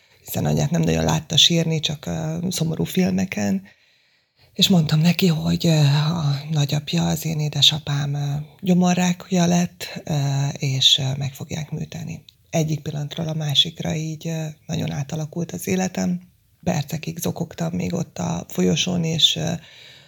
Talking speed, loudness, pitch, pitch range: 115 wpm, -21 LUFS, 160 Hz, 150-170 Hz